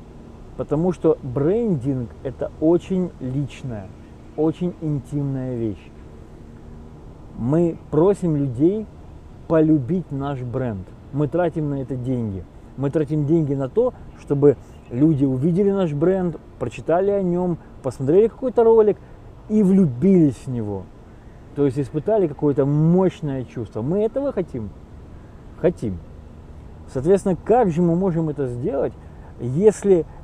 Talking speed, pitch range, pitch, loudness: 115 wpm, 115-175 Hz, 145 Hz, -21 LUFS